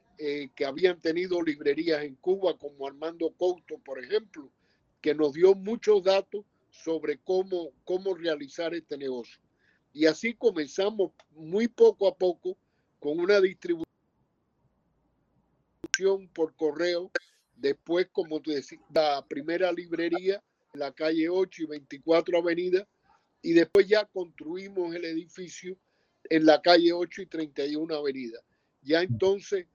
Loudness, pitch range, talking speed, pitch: -28 LUFS, 155-195 Hz, 130 wpm, 175 Hz